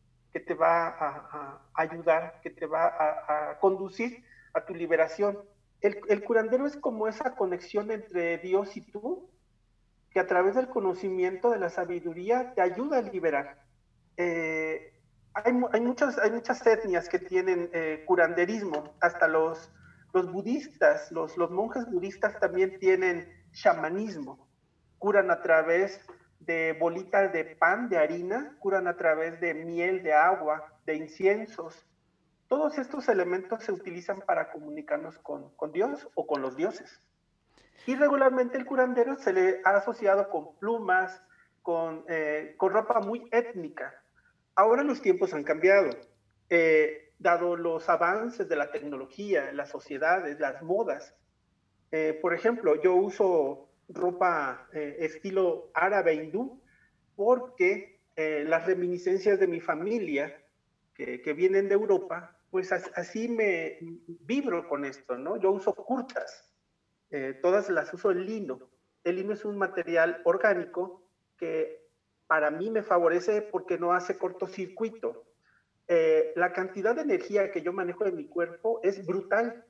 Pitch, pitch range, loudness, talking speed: 190 Hz, 170-235 Hz, -28 LUFS, 145 wpm